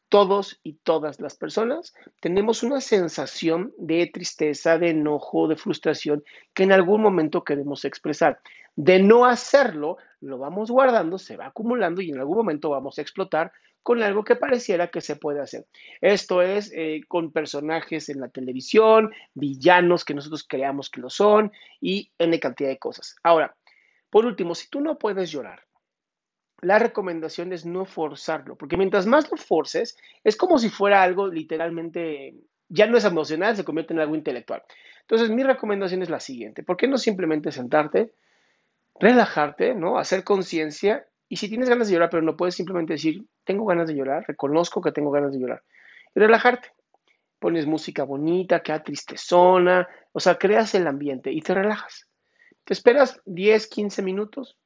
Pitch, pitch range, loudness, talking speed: 180 Hz, 155-215 Hz, -22 LUFS, 170 wpm